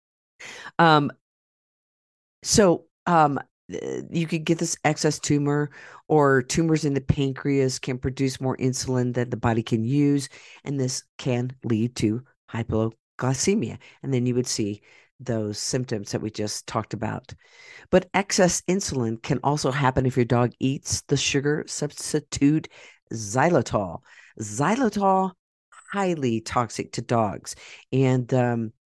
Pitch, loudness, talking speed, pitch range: 130 Hz, -24 LUFS, 130 wpm, 120-150 Hz